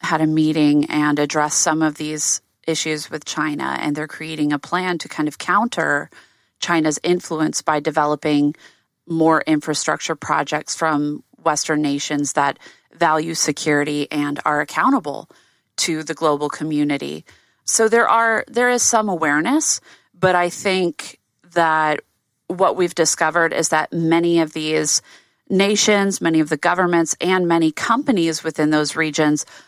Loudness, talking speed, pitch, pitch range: -19 LUFS, 140 wpm, 155 Hz, 150-175 Hz